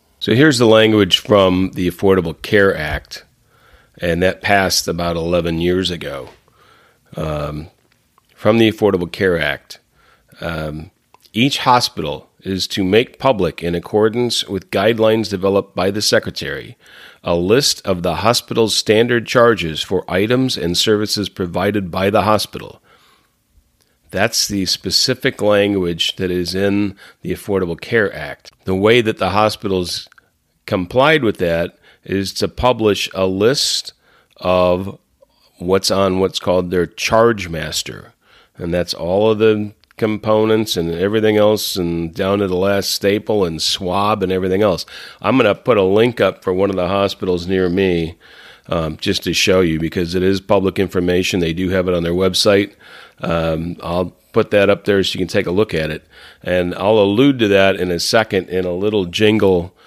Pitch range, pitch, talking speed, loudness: 90-105 Hz, 95 Hz, 160 wpm, -16 LUFS